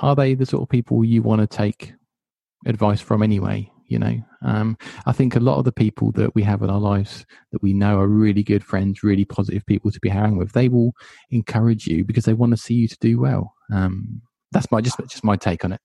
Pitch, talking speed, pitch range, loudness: 110 Hz, 245 wpm, 100-120 Hz, -20 LUFS